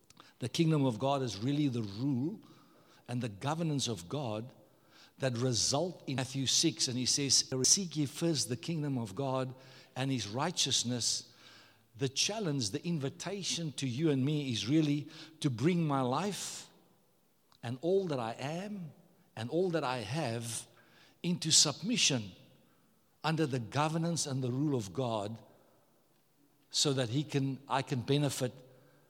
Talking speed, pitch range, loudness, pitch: 150 wpm, 125-160 Hz, -33 LUFS, 135 Hz